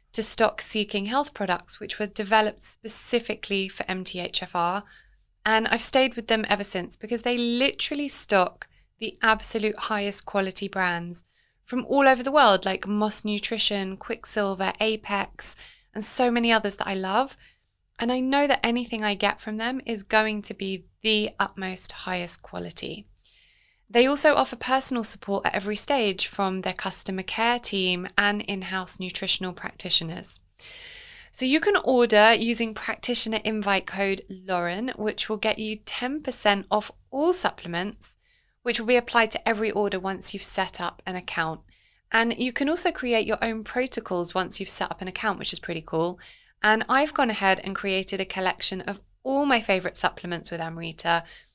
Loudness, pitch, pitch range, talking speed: -25 LUFS, 210 Hz, 190-235 Hz, 165 wpm